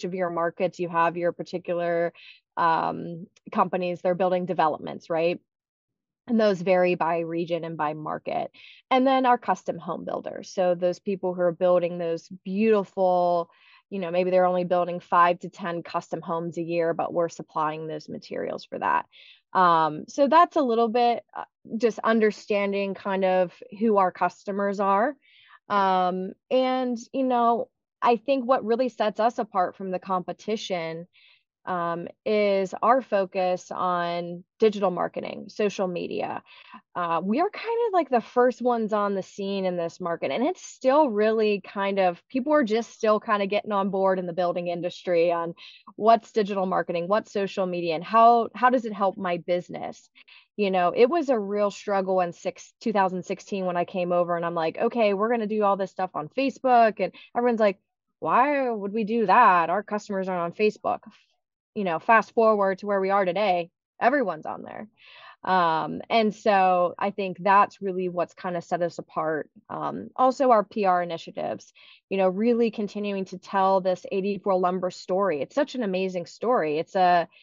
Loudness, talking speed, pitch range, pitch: -25 LUFS, 180 wpm, 175-225 Hz, 195 Hz